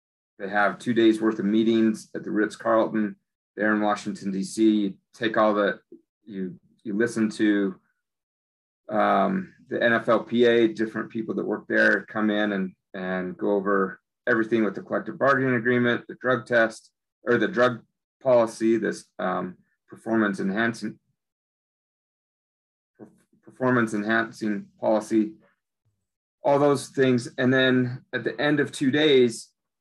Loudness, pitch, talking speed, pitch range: -24 LUFS, 110 Hz, 135 wpm, 105-120 Hz